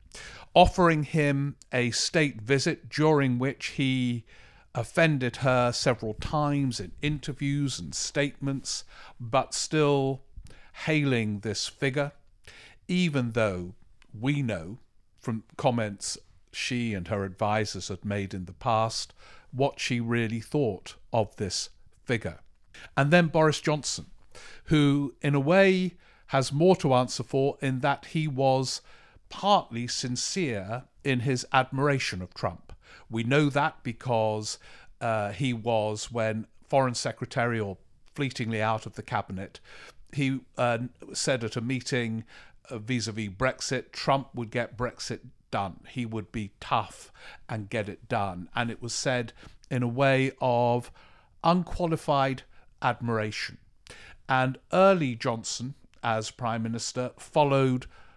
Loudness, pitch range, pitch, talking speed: -28 LUFS, 110-140 Hz, 125 Hz, 125 wpm